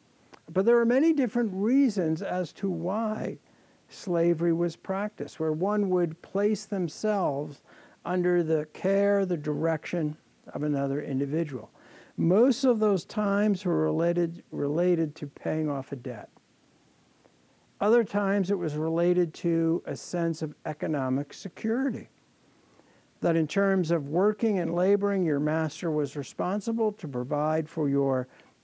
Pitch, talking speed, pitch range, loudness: 175 Hz, 130 wpm, 155-200 Hz, -28 LUFS